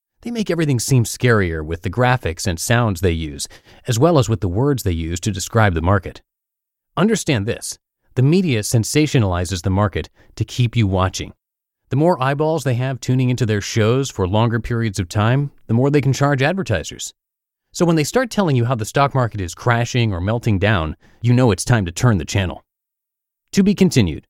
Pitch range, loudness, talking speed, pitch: 100-135 Hz, -18 LUFS, 200 wpm, 120 Hz